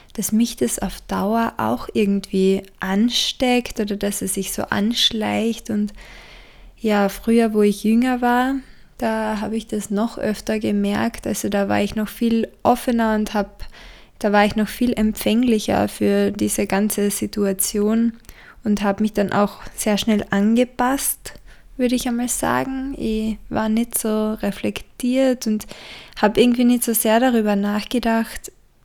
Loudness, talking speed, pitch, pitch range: -20 LUFS, 150 wpm, 215 Hz, 205-230 Hz